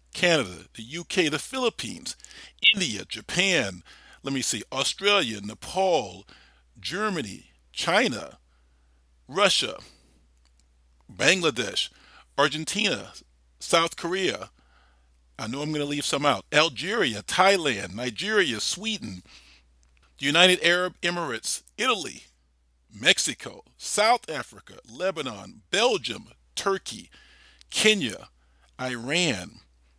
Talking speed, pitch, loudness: 90 wpm, 110 Hz, -24 LUFS